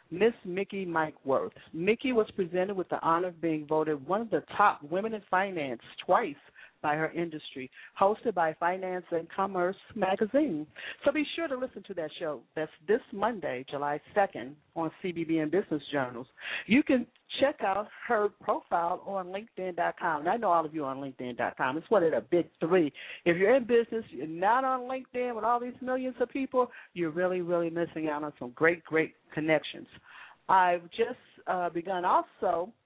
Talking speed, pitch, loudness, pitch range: 175 wpm, 180 Hz, -30 LUFS, 160-220 Hz